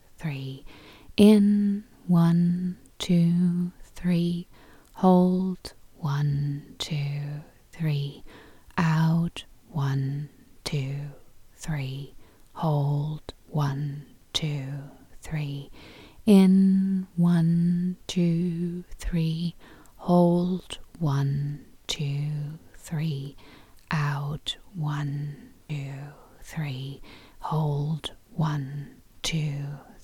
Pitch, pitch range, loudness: 155 Hz, 140-175 Hz, -26 LUFS